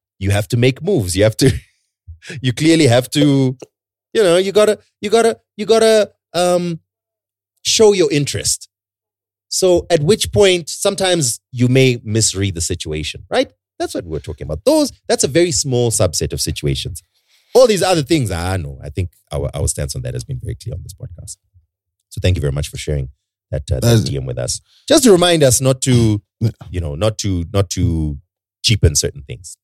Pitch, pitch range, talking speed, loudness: 115 Hz, 95-160 Hz, 195 wpm, -16 LUFS